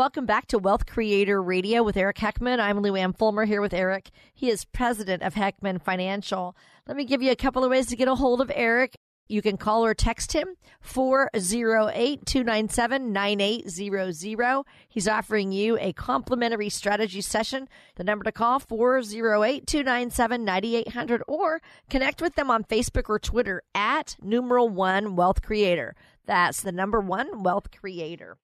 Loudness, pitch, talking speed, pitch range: -25 LUFS, 220 Hz, 155 wpm, 200-250 Hz